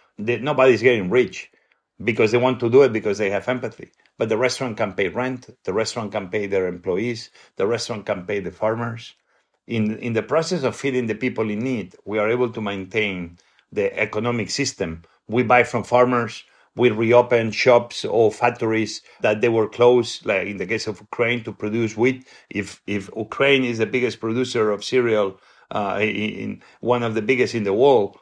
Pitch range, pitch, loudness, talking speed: 110-125 Hz, 115 Hz, -21 LUFS, 195 wpm